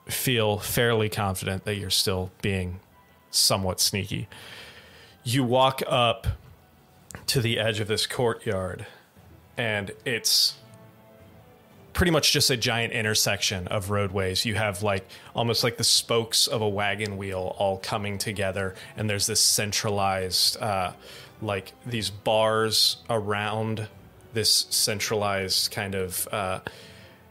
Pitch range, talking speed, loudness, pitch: 95-115 Hz, 125 wpm, -24 LUFS, 105 Hz